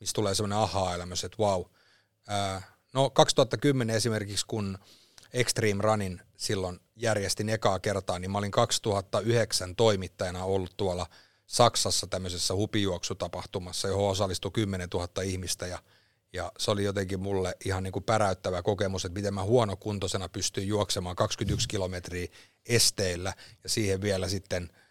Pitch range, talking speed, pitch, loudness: 95-110 Hz, 135 wpm, 100 Hz, -29 LUFS